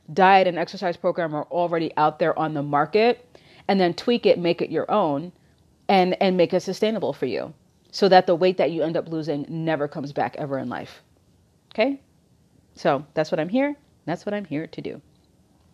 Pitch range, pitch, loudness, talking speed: 155-190 Hz, 175 Hz, -23 LUFS, 200 wpm